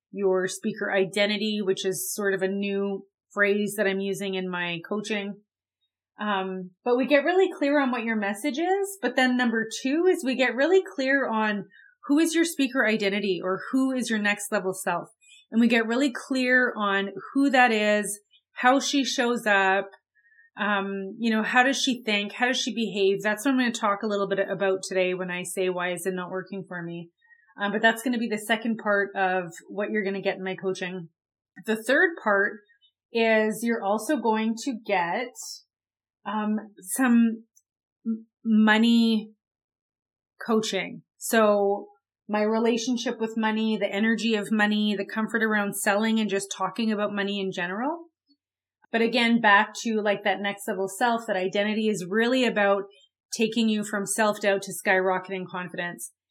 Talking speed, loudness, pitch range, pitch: 175 wpm, -25 LUFS, 195-235 Hz, 210 Hz